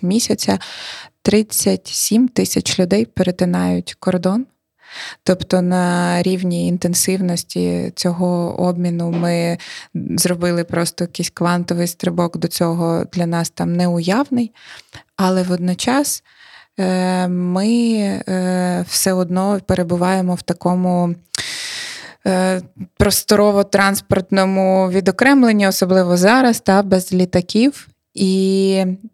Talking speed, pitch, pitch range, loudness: 85 wpm, 185 Hz, 175-195 Hz, -17 LUFS